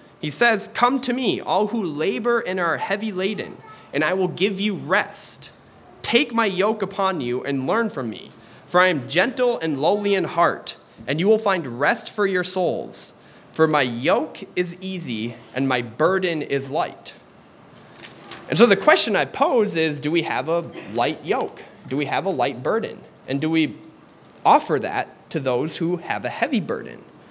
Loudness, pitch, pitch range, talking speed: -22 LUFS, 180 Hz, 150-205 Hz, 185 wpm